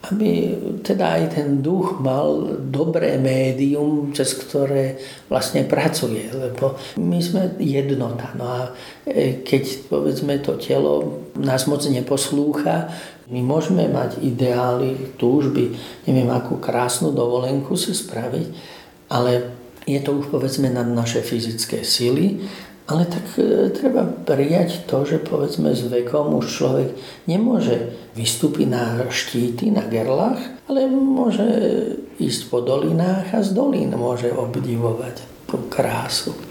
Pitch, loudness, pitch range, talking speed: 135 Hz, -20 LUFS, 120-175 Hz, 120 wpm